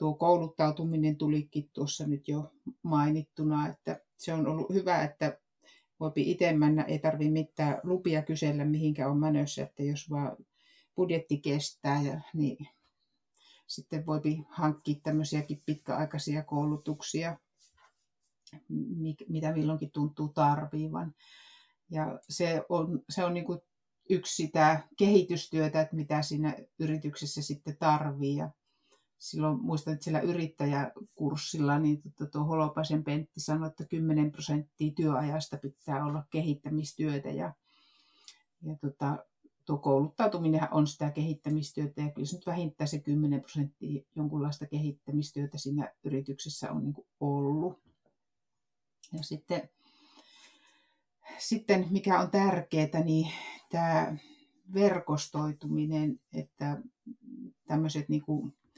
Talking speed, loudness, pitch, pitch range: 105 wpm, -32 LUFS, 155 Hz, 150-160 Hz